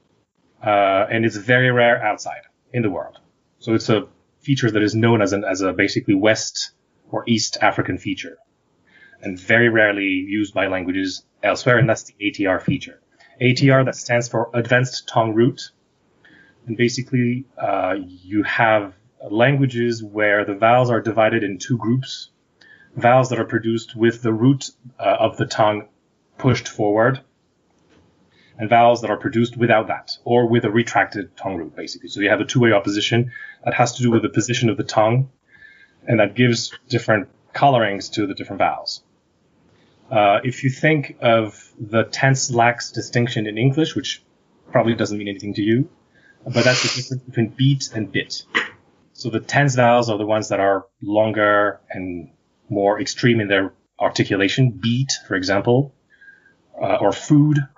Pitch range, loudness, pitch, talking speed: 110-125 Hz, -19 LUFS, 115 Hz, 165 wpm